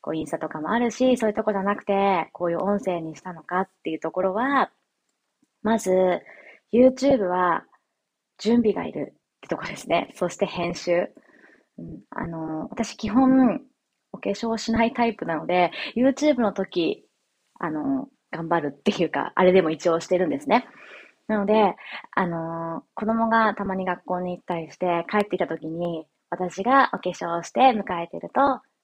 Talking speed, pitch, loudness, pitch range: 330 characters per minute, 200 Hz, -24 LUFS, 175-240 Hz